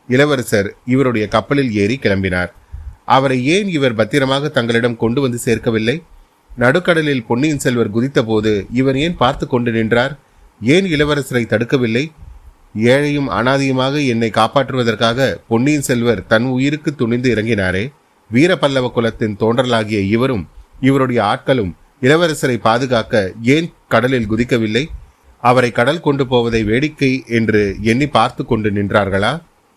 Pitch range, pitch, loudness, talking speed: 110-135 Hz, 120 Hz, -15 LUFS, 115 wpm